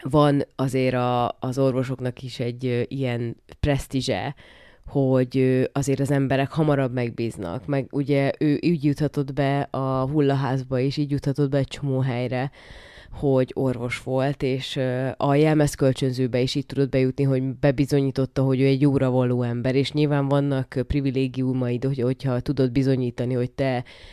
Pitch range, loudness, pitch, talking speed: 130-140 Hz, -23 LUFS, 135 Hz, 145 wpm